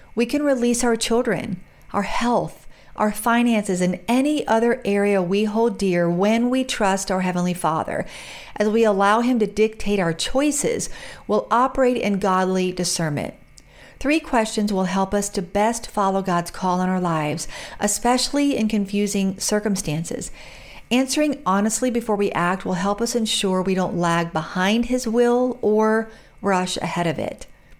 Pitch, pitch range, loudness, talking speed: 205 Hz, 185-235 Hz, -21 LUFS, 155 wpm